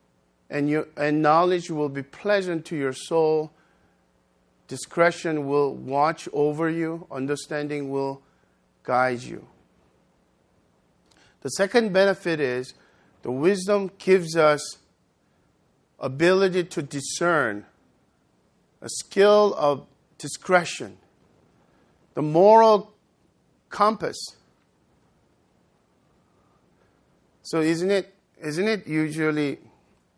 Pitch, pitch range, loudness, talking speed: 155 Hz, 135-180 Hz, -23 LUFS, 85 wpm